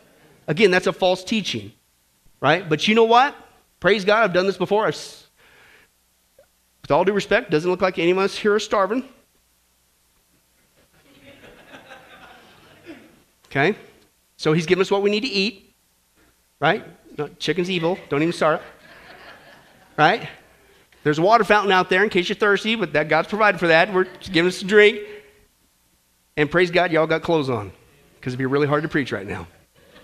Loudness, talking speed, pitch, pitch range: -19 LUFS, 175 wpm, 175 Hz, 120-200 Hz